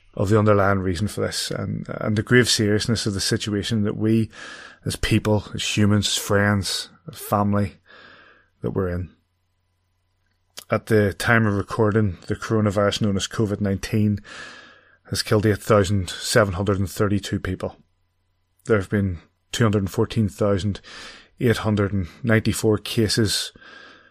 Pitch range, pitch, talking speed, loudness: 95-110 Hz, 105 Hz, 150 wpm, -22 LUFS